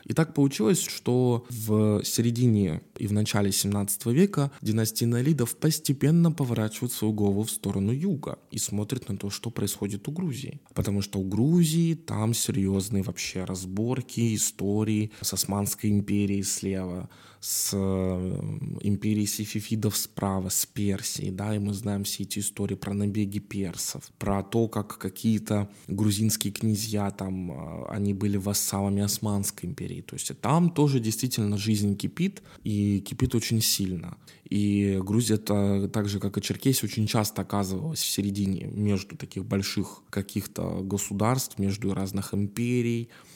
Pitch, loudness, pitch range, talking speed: 105 Hz, -27 LUFS, 100-115 Hz, 140 wpm